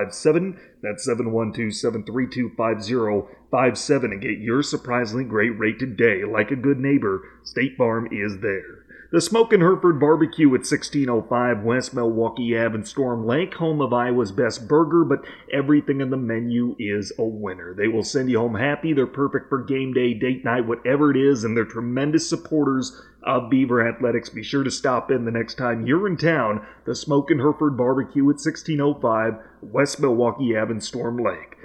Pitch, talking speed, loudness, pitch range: 125 Hz, 190 wpm, -22 LUFS, 115-145 Hz